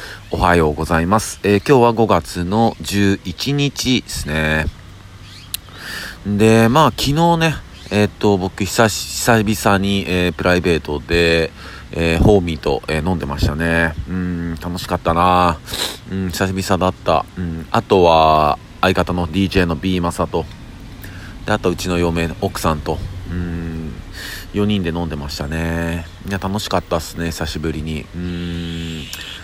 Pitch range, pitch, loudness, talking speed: 85-100 Hz, 90 Hz, -17 LUFS, 270 characters per minute